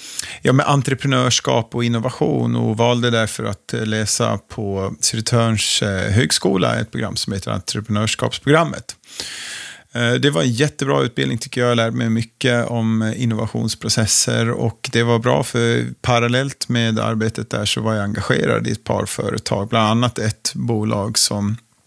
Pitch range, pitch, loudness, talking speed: 110-120 Hz, 115 Hz, -18 LUFS, 145 wpm